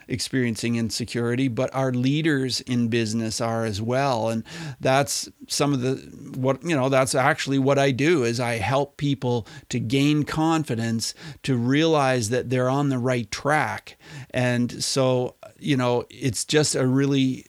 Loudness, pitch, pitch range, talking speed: -23 LUFS, 130 Hz, 120-140 Hz, 160 wpm